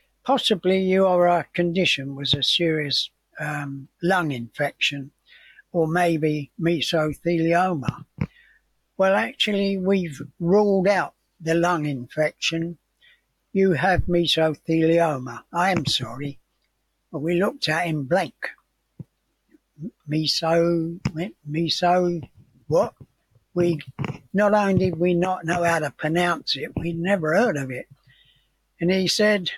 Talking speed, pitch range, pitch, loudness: 115 wpm, 150-180 Hz, 170 Hz, -22 LUFS